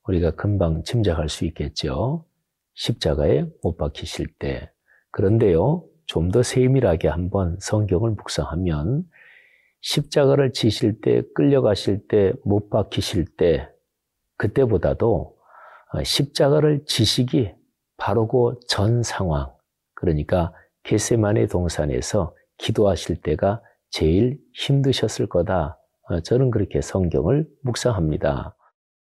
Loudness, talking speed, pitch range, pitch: -22 LUFS, 235 characters per minute, 85-130 Hz, 105 Hz